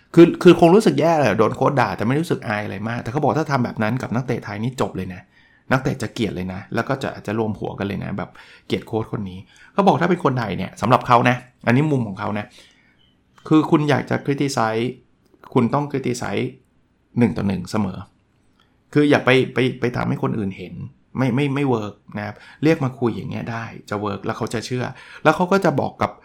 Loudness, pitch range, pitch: -20 LUFS, 105-140 Hz, 120 Hz